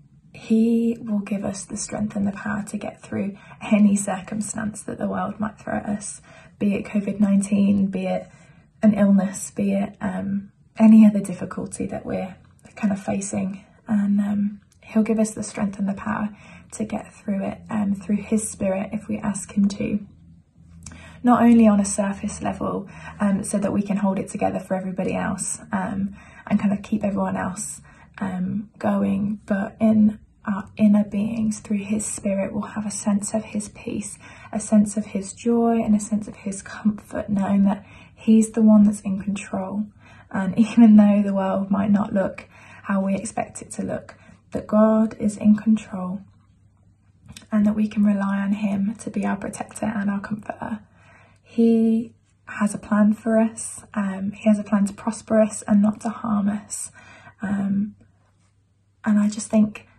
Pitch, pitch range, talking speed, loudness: 205 Hz, 195-215 Hz, 180 wpm, -22 LUFS